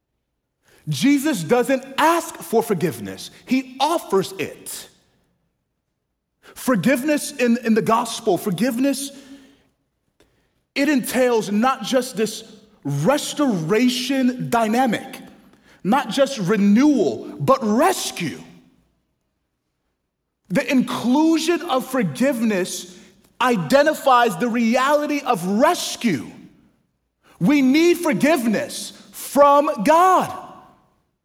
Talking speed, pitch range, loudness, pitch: 75 wpm, 220-280 Hz, -19 LUFS, 255 Hz